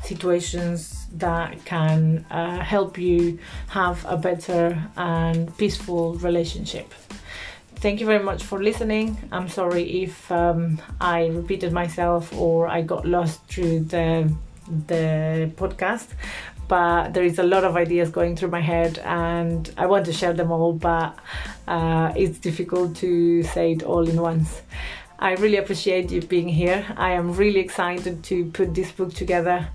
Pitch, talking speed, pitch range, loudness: 175 Hz, 155 wpm, 170-185 Hz, -23 LUFS